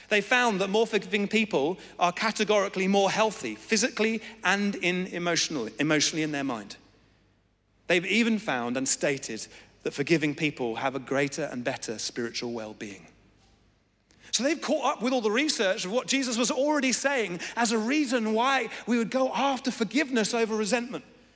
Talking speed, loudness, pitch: 165 wpm, -27 LUFS, 200 Hz